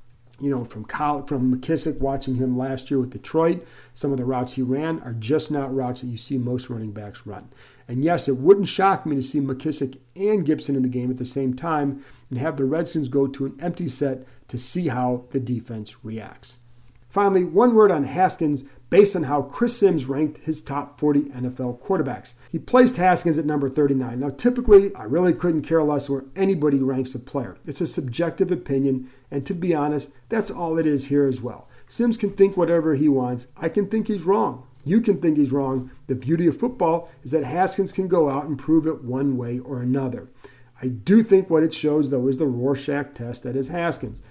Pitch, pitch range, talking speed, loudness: 140 Hz, 130-165 Hz, 215 wpm, -22 LUFS